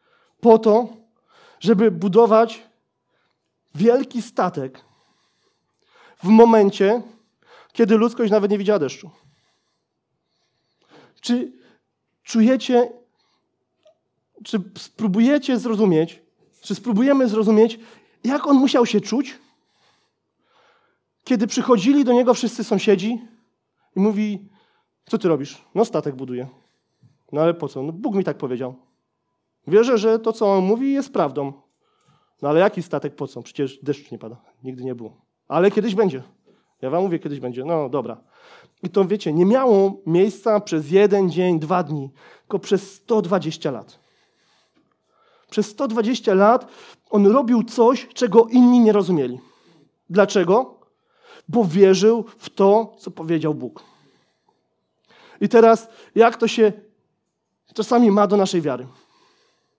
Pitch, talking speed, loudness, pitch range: 210 Hz, 125 wpm, -19 LUFS, 170-235 Hz